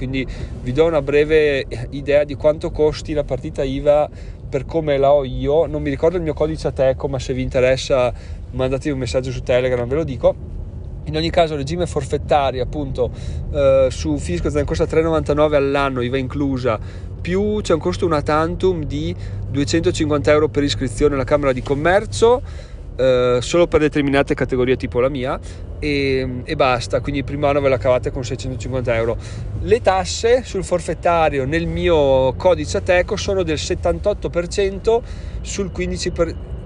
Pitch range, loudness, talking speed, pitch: 125-155 Hz, -19 LUFS, 160 wpm, 140 Hz